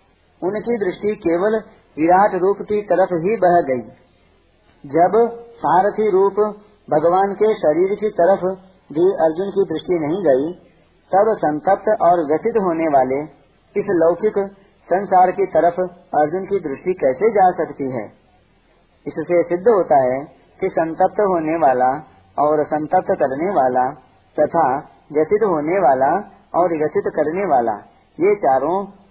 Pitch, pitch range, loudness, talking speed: 180 Hz, 150-200 Hz, -18 LUFS, 130 wpm